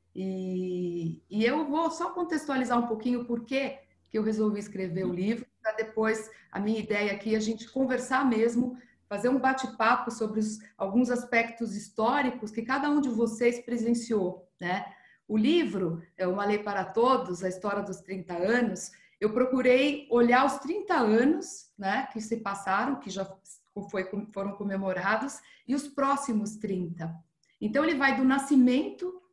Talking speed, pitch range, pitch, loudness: 160 wpm, 200-260 Hz, 225 Hz, -29 LUFS